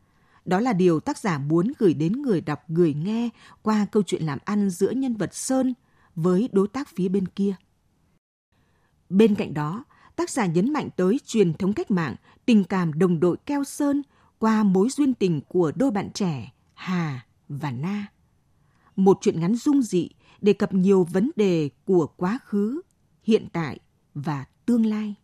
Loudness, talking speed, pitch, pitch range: -24 LUFS, 175 wpm, 195 Hz, 175-220 Hz